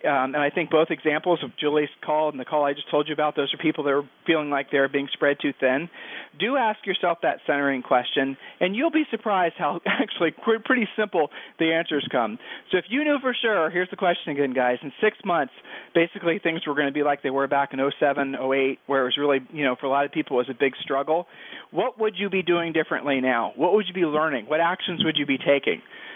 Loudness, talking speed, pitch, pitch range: -24 LUFS, 245 wpm, 150 Hz, 140-175 Hz